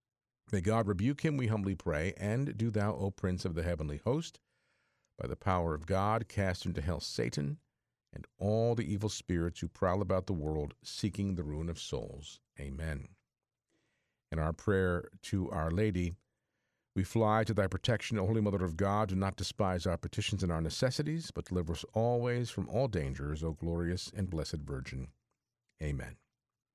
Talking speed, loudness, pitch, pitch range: 175 wpm, -35 LUFS, 95 Hz, 85-110 Hz